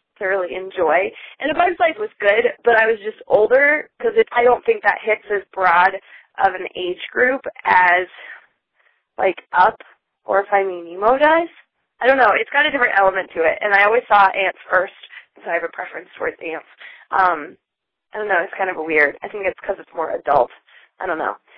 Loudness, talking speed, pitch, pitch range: -17 LUFS, 210 wpm, 215 Hz, 190-290 Hz